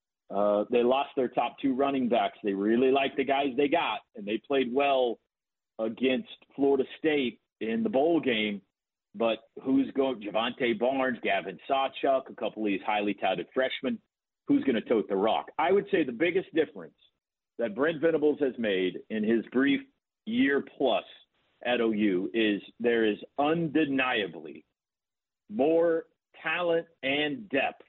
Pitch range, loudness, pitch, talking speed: 115-150 Hz, -28 LUFS, 135 Hz, 155 wpm